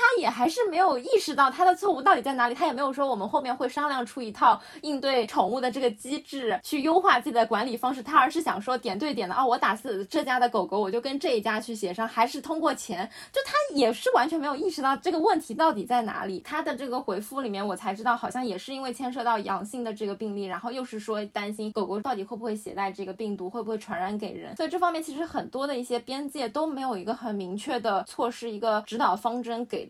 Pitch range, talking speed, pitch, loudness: 220-290 Hz, 385 characters per minute, 245 Hz, -27 LUFS